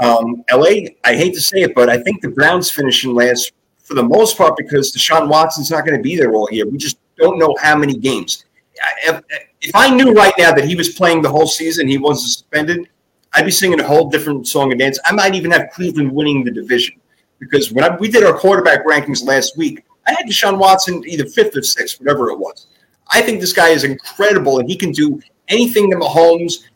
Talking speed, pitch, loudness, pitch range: 230 wpm, 165 Hz, -13 LUFS, 140-195 Hz